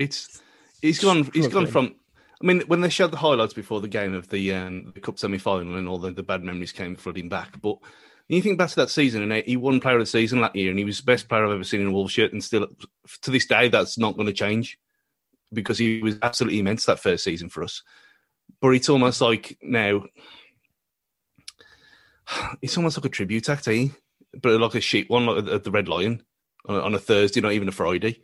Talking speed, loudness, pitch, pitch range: 235 wpm, -23 LUFS, 110 Hz, 100-130 Hz